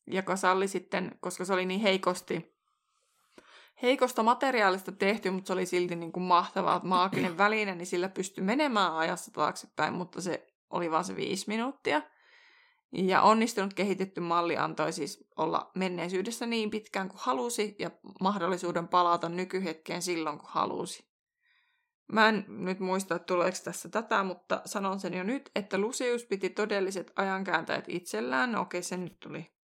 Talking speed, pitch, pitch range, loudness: 155 wpm, 190 Hz, 180-215 Hz, -30 LUFS